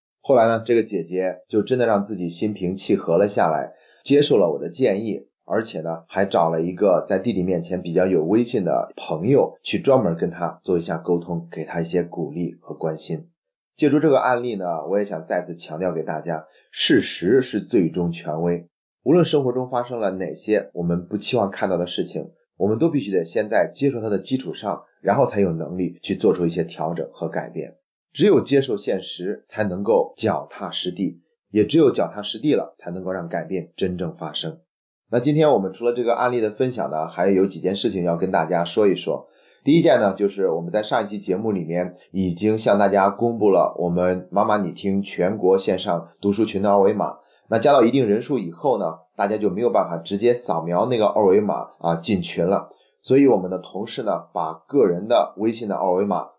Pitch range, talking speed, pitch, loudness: 90-115 Hz, 310 characters per minute, 95 Hz, -21 LUFS